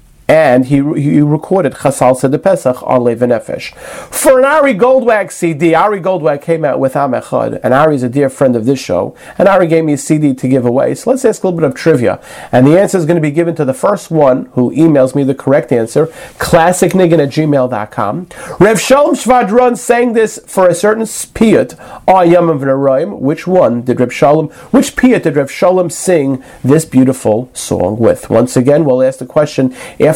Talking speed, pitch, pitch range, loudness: 200 wpm, 155 Hz, 135-185 Hz, -11 LUFS